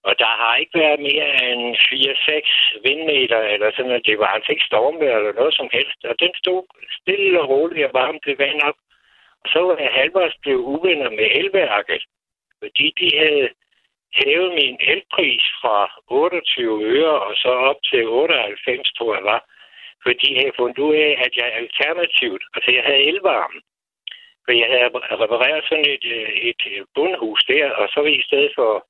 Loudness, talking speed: -17 LUFS, 180 wpm